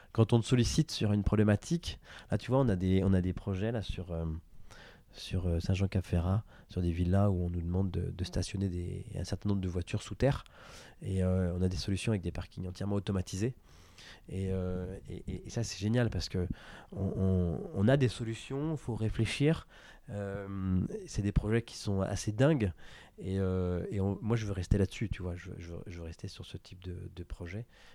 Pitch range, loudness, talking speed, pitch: 90-110 Hz, -33 LUFS, 215 wpm, 95 Hz